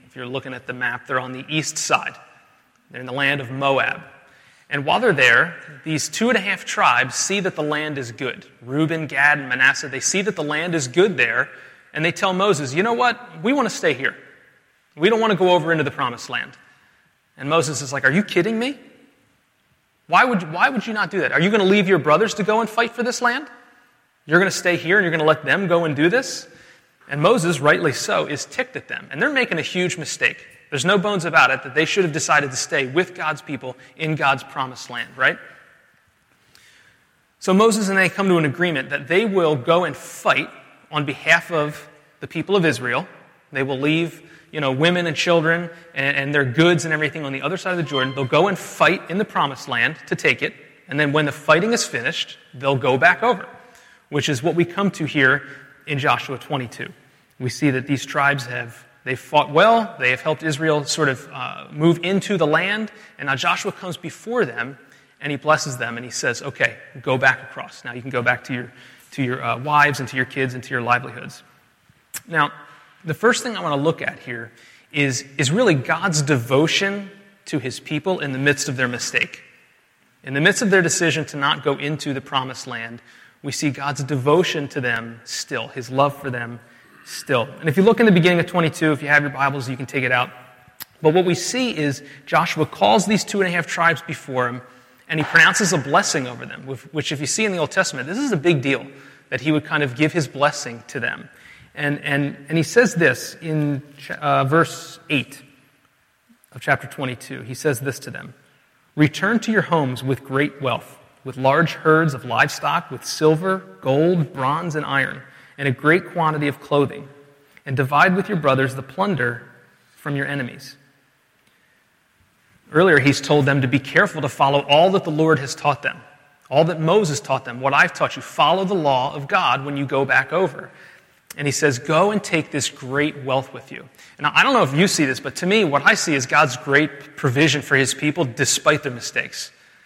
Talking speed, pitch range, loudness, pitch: 220 wpm, 135-170 Hz, -19 LUFS, 150 Hz